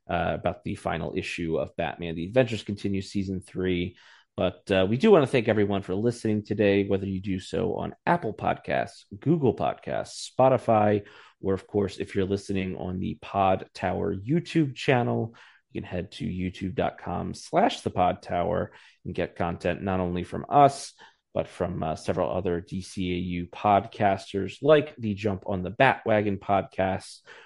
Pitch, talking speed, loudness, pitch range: 100 Hz, 165 wpm, -27 LUFS, 90-110 Hz